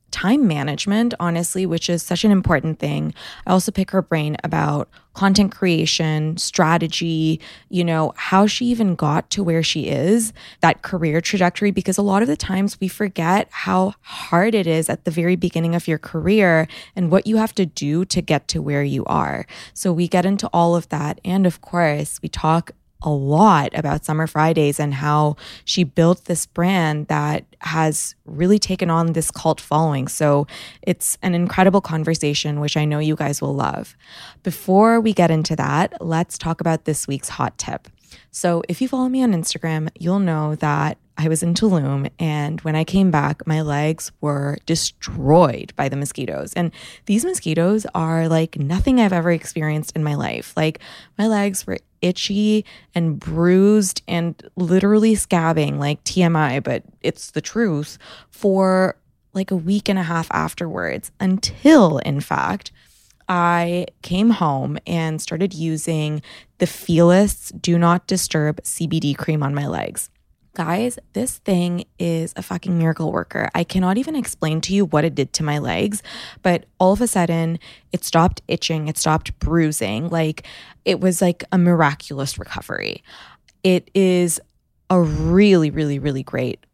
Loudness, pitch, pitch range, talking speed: -19 LUFS, 170 Hz, 155-185 Hz, 170 wpm